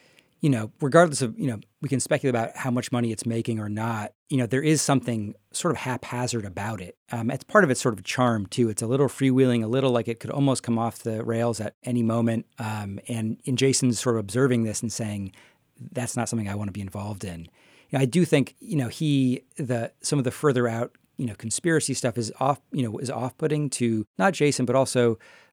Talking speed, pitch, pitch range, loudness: 235 wpm, 125 Hz, 115-135 Hz, -25 LUFS